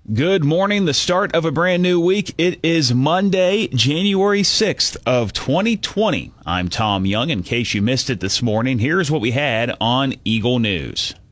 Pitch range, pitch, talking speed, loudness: 115-180 Hz, 135 Hz, 175 wpm, -18 LUFS